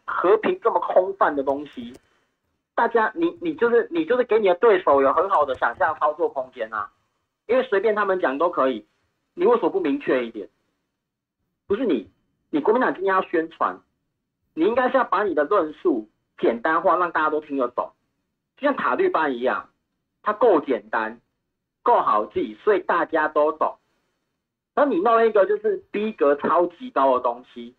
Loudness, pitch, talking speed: -22 LUFS, 240 Hz, 260 characters per minute